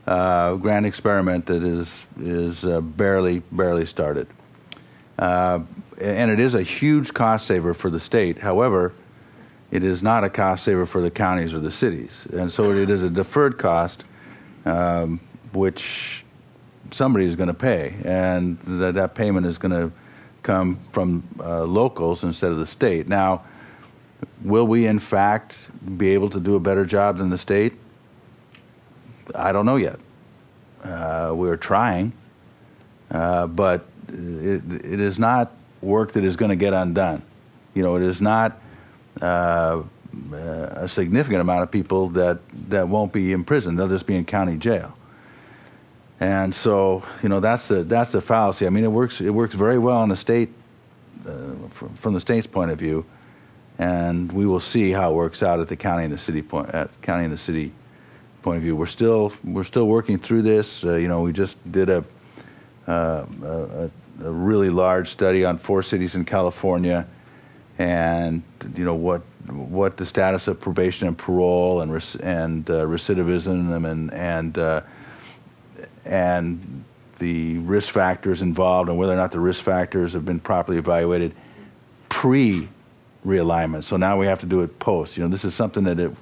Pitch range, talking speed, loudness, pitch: 85-100 Hz, 175 wpm, -22 LUFS, 90 Hz